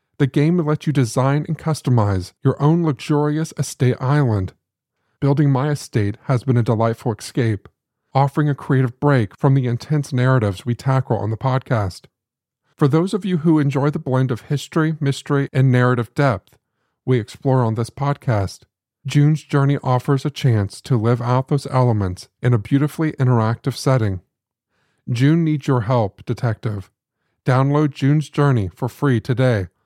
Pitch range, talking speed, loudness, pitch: 120-145 Hz, 160 wpm, -19 LUFS, 130 Hz